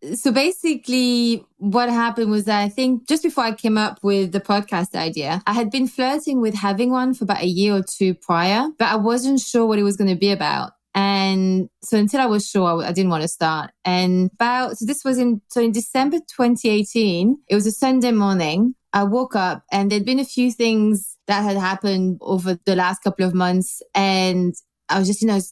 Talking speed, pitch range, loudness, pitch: 215 wpm, 190-245 Hz, -19 LUFS, 210 Hz